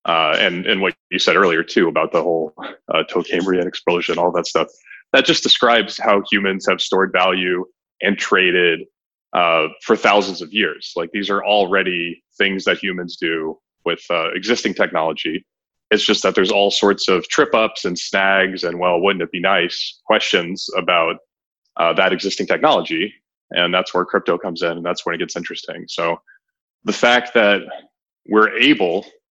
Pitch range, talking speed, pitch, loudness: 90-100 Hz, 175 wpm, 95 Hz, -17 LUFS